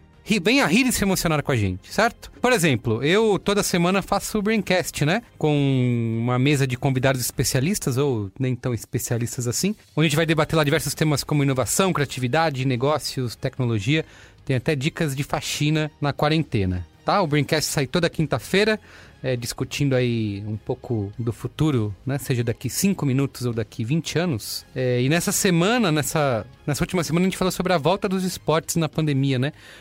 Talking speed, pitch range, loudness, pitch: 185 wpm, 125-170 Hz, -22 LUFS, 145 Hz